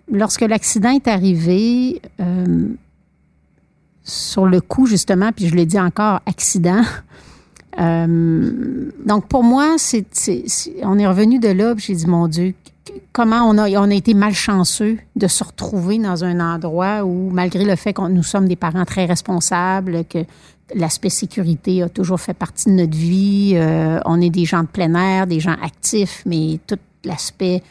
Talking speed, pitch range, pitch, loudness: 170 wpm, 175-210 Hz, 190 Hz, -16 LUFS